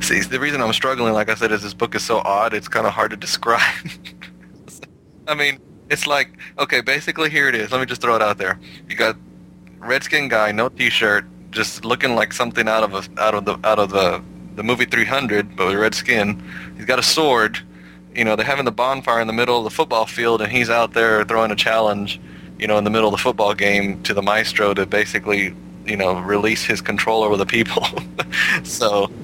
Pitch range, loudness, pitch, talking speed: 95-115 Hz, -18 LUFS, 105 Hz, 225 wpm